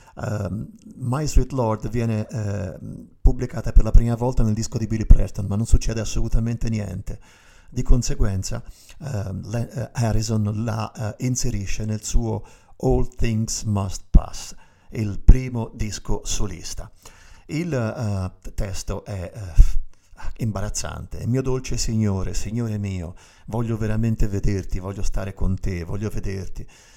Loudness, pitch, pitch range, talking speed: -25 LUFS, 110 Hz, 100-115 Hz, 135 wpm